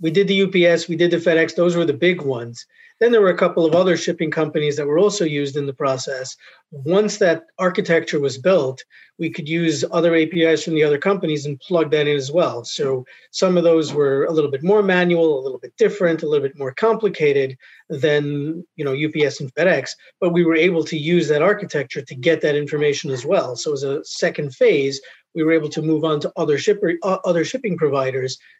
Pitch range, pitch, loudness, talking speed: 145-180 Hz, 160 Hz, -19 LUFS, 220 wpm